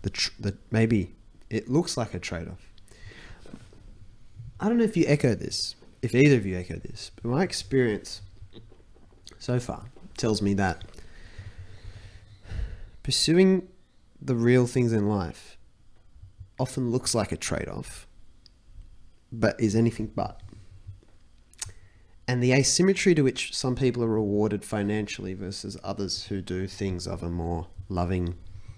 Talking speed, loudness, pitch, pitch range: 140 wpm, -26 LUFS, 100 Hz, 95-115 Hz